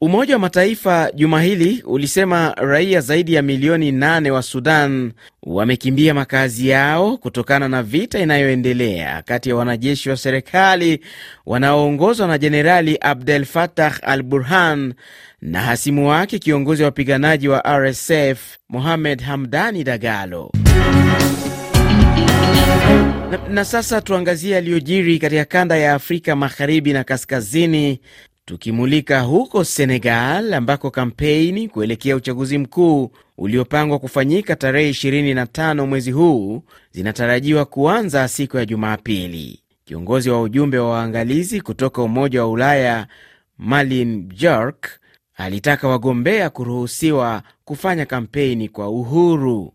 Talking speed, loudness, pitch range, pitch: 110 wpm, -16 LUFS, 125-155 Hz, 140 Hz